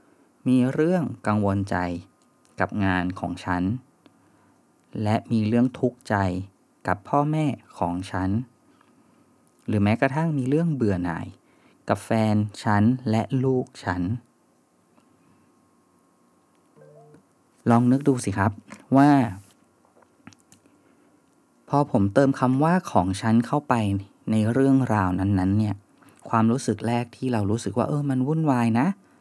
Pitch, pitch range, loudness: 115 Hz, 100-130 Hz, -24 LUFS